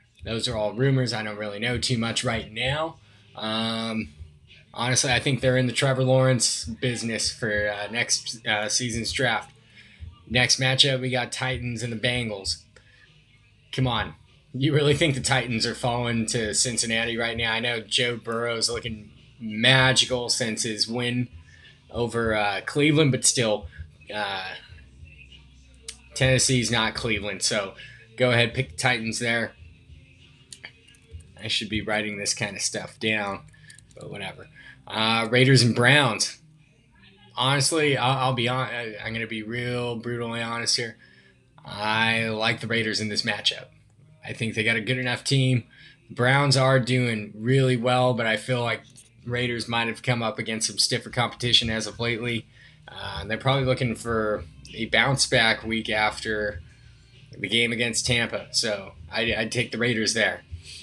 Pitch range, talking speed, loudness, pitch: 110-125 Hz, 155 wpm, -24 LUFS, 115 Hz